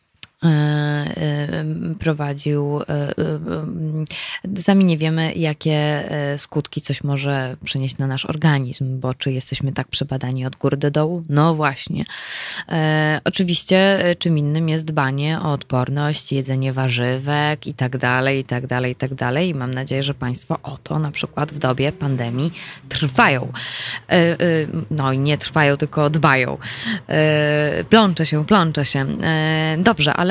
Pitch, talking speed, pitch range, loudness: 150 Hz, 145 wpm, 135-160 Hz, -20 LUFS